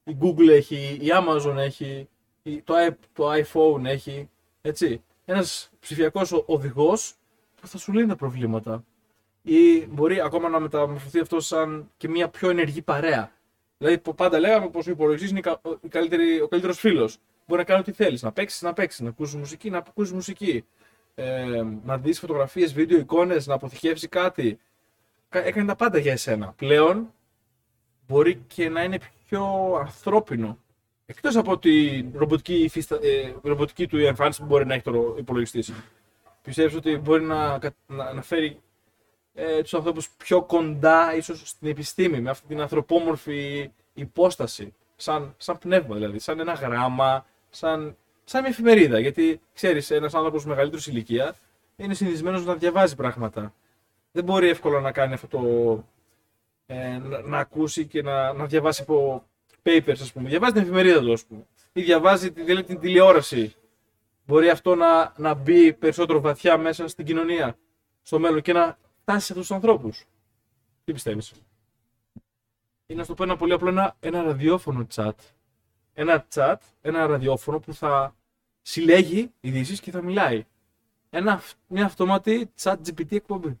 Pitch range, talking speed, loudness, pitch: 115-170 Hz, 150 wpm, -23 LUFS, 150 Hz